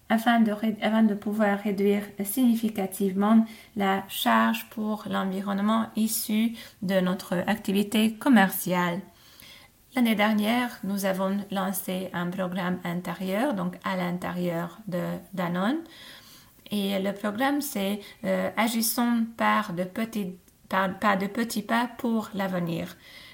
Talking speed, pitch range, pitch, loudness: 115 wpm, 190-220 Hz, 200 Hz, -26 LUFS